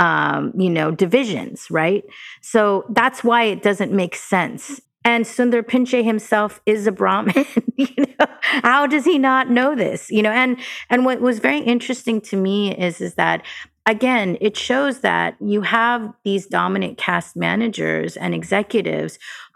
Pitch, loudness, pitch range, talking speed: 225 Hz, -18 LUFS, 200-250 Hz, 160 wpm